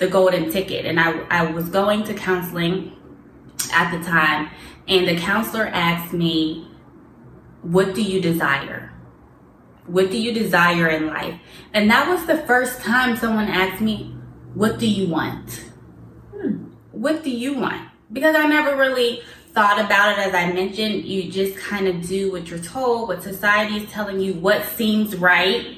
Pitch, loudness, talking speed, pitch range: 190 Hz, -20 LUFS, 170 wpm, 170-215 Hz